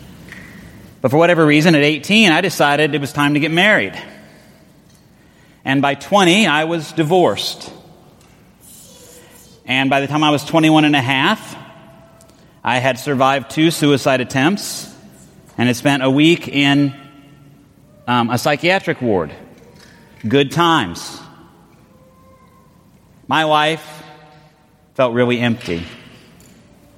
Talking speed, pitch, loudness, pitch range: 120 wpm, 145 Hz, -15 LUFS, 135-160 Hz